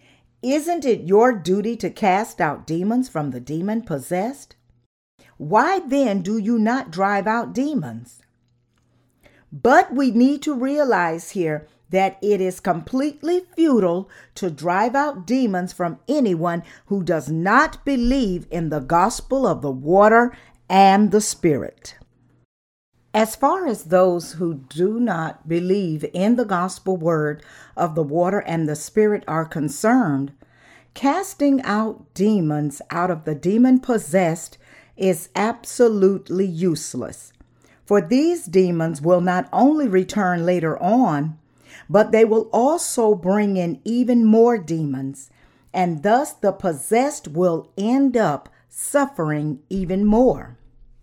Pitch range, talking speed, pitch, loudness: 165-235 Hz, 130 wpm, 190 Hz, -20 LUFS